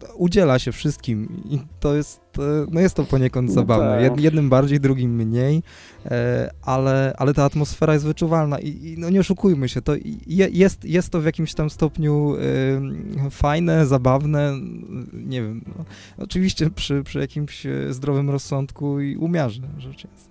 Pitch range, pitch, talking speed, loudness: 130-160 Hz, 145 Hz, 145 wpm, -21 LUFS